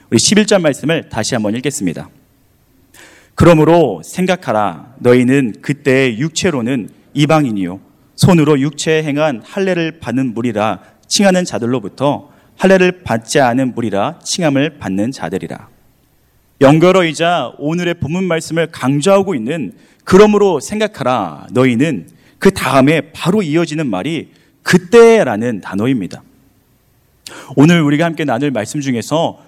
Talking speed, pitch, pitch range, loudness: 295 characters per minute, 150 Hz, 125-170 Hz, -13 LUFS